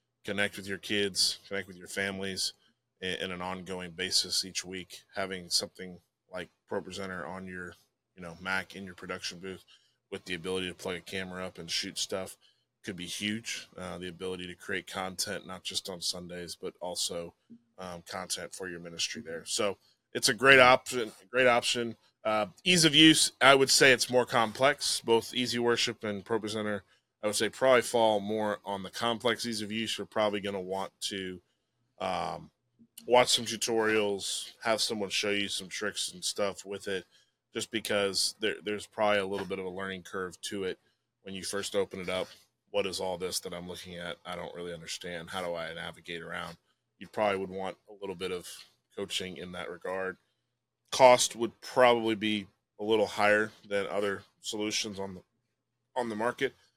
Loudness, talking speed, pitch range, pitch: -30 LUFS, 190 wpm, 95-115 Hz, 100 Hz